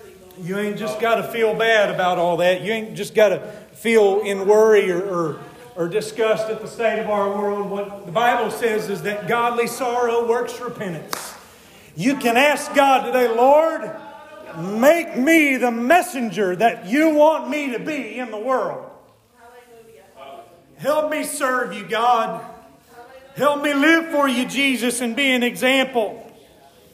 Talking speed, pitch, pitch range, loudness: 160 wpm, 235 Hz, 210-260 Hz, -19 LUFS